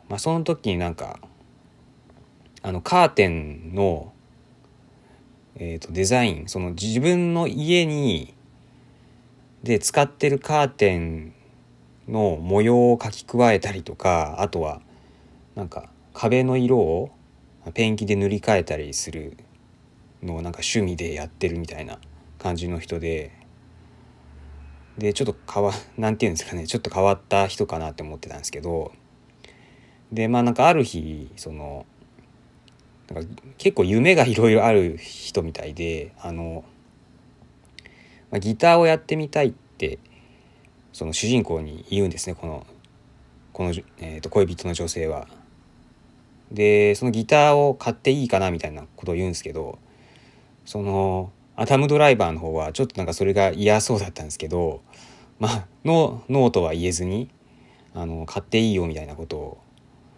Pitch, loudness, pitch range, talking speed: 100 Hz, -22 LUFS, 80-125 Hz, 275 characters per minute